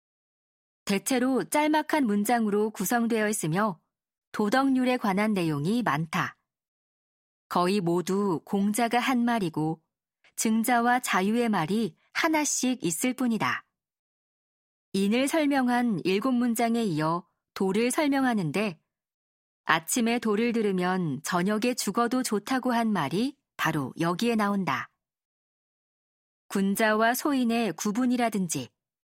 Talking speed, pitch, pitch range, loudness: 235 characters per minute, 220 Hz, 195-245 Hz, -26 LUFS